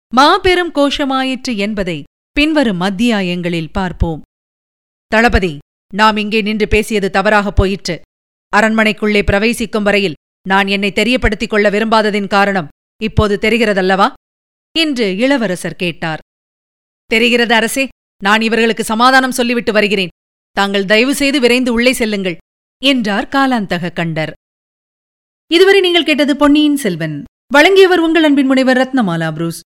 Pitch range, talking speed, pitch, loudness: 195-255 Hz, 110 wpm, 220 Hz, -13 LUFS